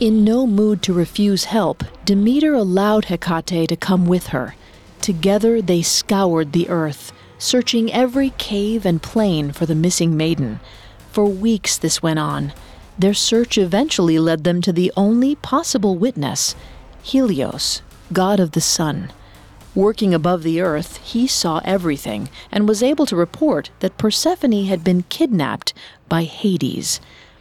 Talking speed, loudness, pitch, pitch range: 145 wpm, -18 LUFS, 190 Hz, 165-220 Hz